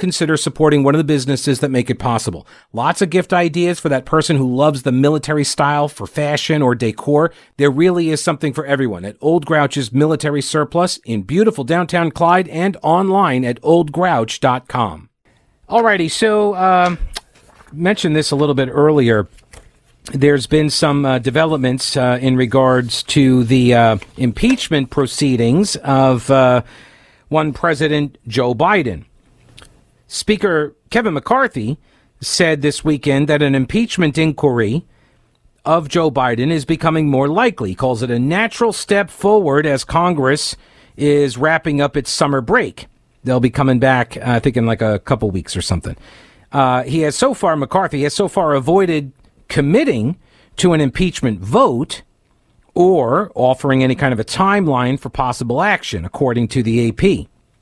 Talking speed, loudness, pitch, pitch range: 155 wpm, -15 LUFS, 145 Hz, 130-165 Hz